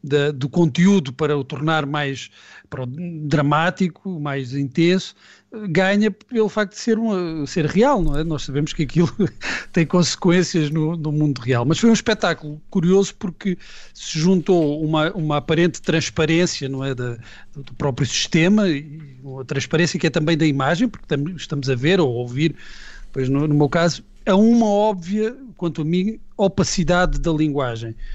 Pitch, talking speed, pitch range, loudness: 160 Hz, 170 wpm, 145-185 Hz, -20 LUFS